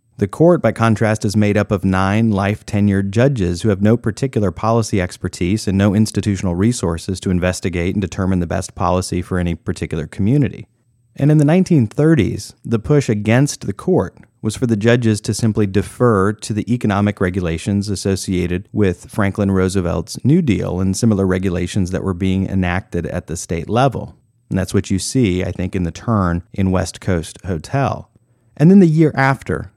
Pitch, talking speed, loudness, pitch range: 100 Hz, 180 wpm, -17 LUFS, 95-115 Hz